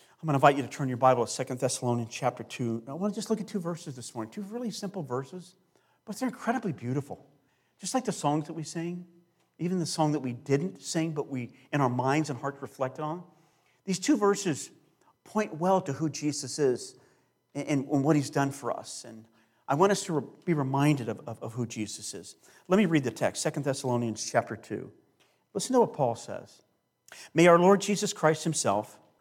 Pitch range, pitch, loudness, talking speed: 130-180 Hz, 150 Hz, -29 LUFS, 205 wpm